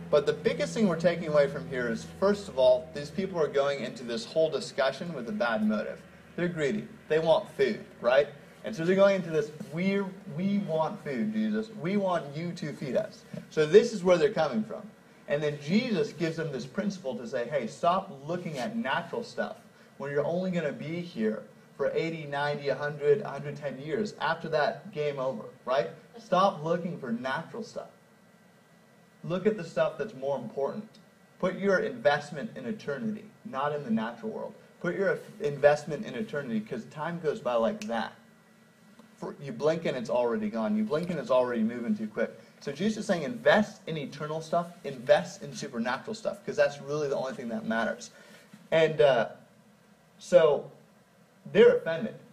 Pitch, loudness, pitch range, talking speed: 195 Hz, -29 LUFS, 150-215 Hz, 185 wpm